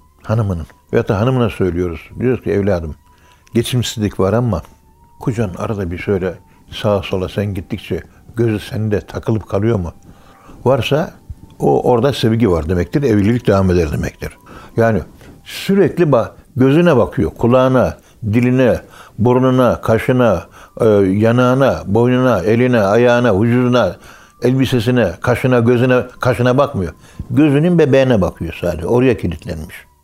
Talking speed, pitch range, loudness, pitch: 120 wpm, 90-125 Hz, -15 LUFS, 115 Hz